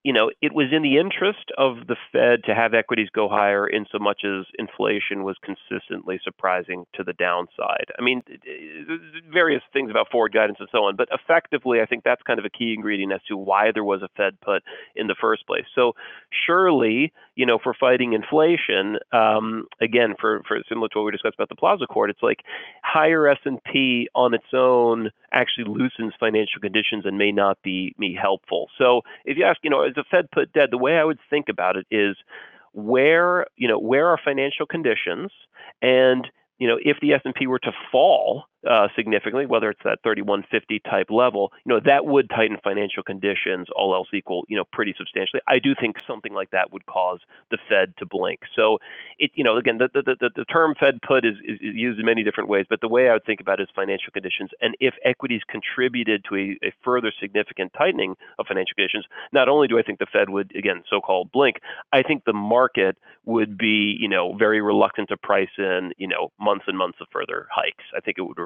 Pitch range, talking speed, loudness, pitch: 105-140 Hz, 215 wpm, -21 LUFS, 120 Hz